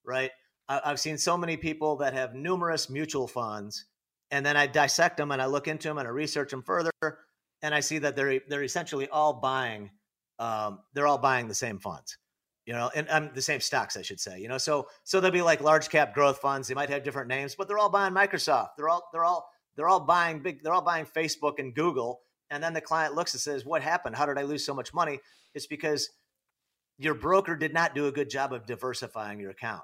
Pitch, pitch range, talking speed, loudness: 145 Hz, 130-160 Hz, 235 wpm, -28 LUFS